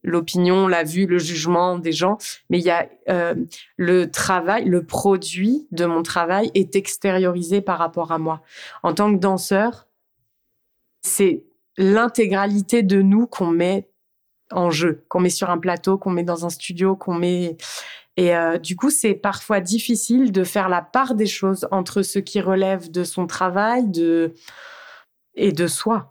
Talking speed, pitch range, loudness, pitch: 170 wpm, 175-200 Hz, -20 LUFS, 185 Hz